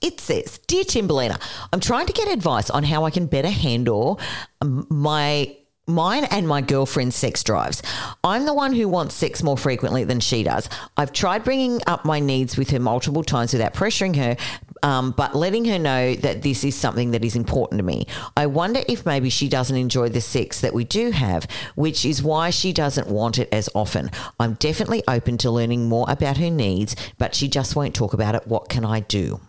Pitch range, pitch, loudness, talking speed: 120-160 Hz, 140 Hz, -21 LUFS, 210 wpm